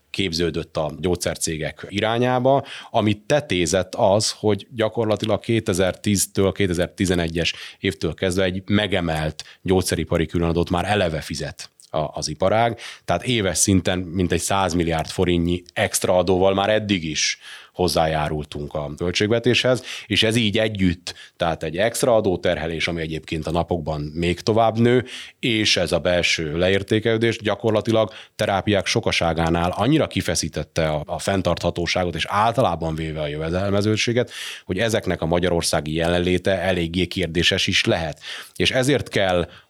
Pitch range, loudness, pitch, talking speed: 85-105 Hz, -21 LUFS, 95 Hz, 120 wpm